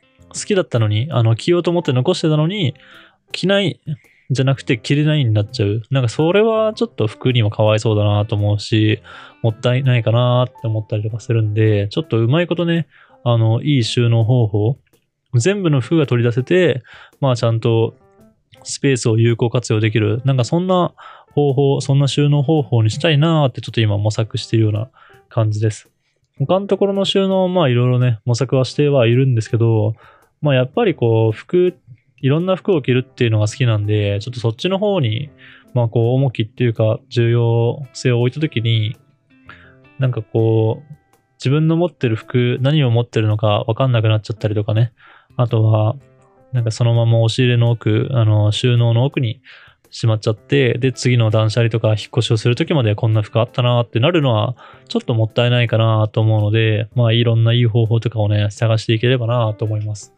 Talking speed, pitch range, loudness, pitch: 395 characters per minute, 110-140 Hz, -17 LUFS, 120 Hz